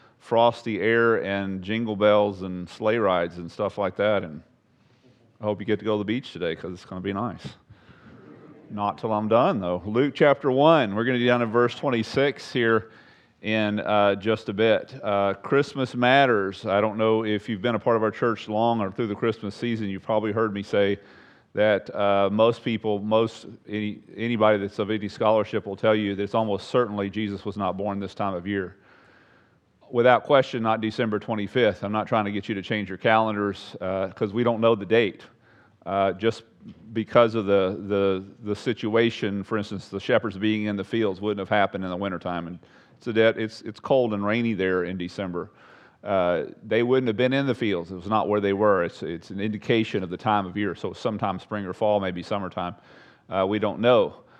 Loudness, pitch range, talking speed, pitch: -24 LUFS, 100-115 Hz, 210 wpm, 105 Hz